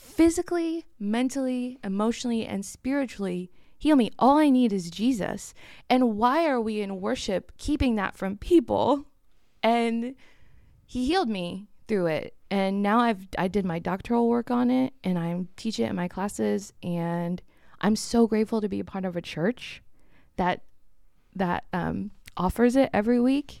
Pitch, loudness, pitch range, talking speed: 225 Hz, -26 LUFS, 190-255 Hz, 160 wpm